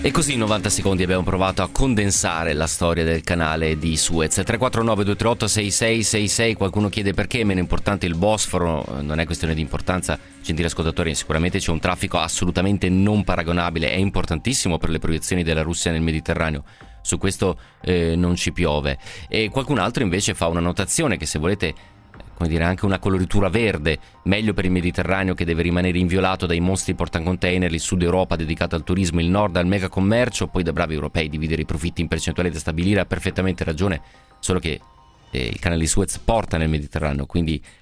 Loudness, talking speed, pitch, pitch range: -21 LUFS, 185 wpm, 90 Hz, 80-100 Hz